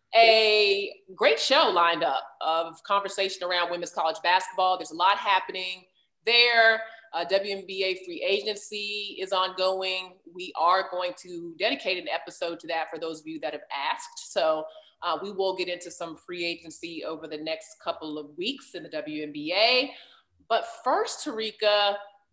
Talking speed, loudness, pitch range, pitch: 160 wpm, -26 LUFS, 170-210 Hz, 185 Hz